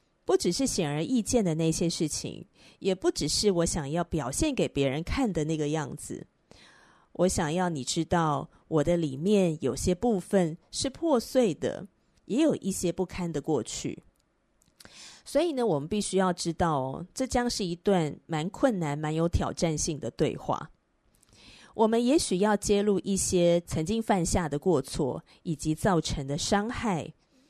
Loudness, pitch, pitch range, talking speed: -28 LUFS, 175 Hz, 160-210 Hz, 235 characters per minute